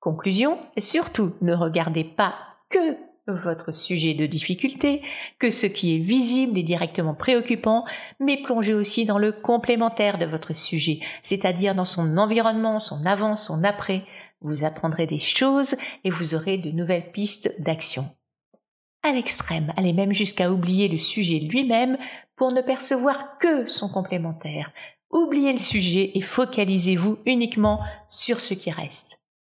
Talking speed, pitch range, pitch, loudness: 145 wpm, 170-245 Hz, 200 Hz, -22 LUFS